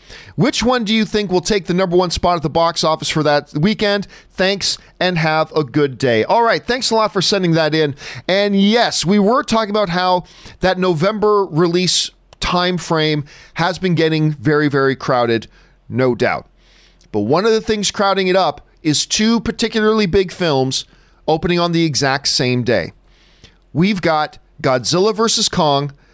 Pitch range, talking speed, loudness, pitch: 150-200 Hz, 175 wpm, -16 LUFS, 175 Hz